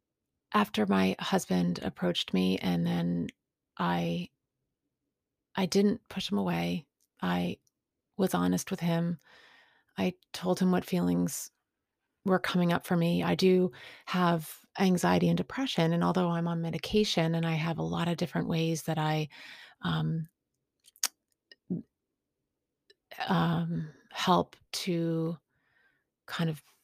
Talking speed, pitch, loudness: 125 wpm, 165 Hz, -30 LUFS